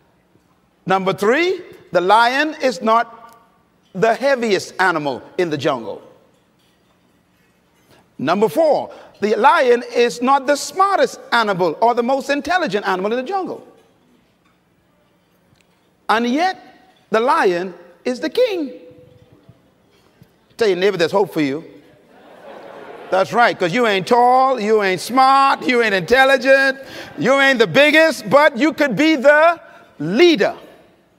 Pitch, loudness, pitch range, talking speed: 245 Hz, -16 LUFS, 190-295 Hz, 125 wpm